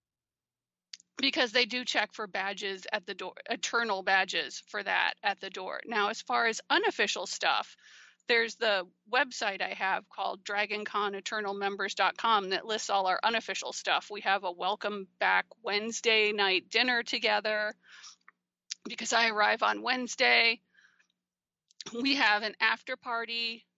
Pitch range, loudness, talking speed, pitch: 195-235 Hz, -29 LUFS, 135 wpm, 215 Hz